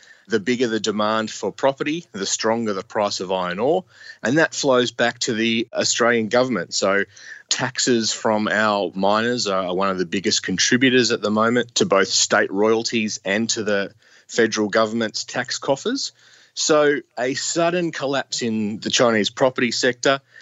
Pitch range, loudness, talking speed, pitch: 110-130 Hz, -20 LUFS, 160 wpm, 115 Hz